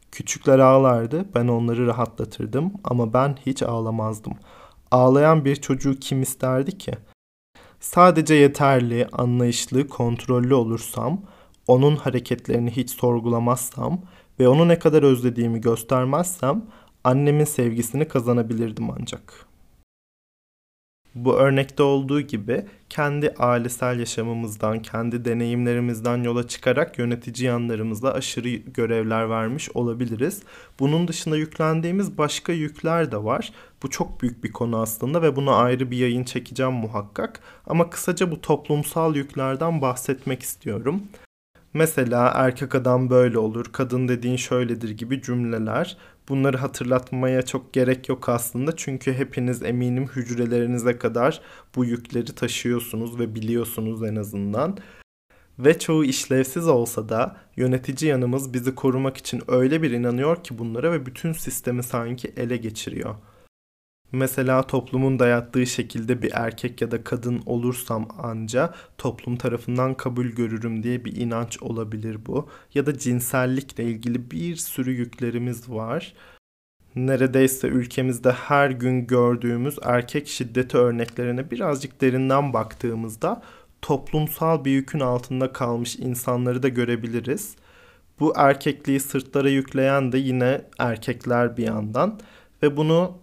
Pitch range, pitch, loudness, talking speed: 120-140 Hz, 125 Hz, -23 LUFS, 120 wpm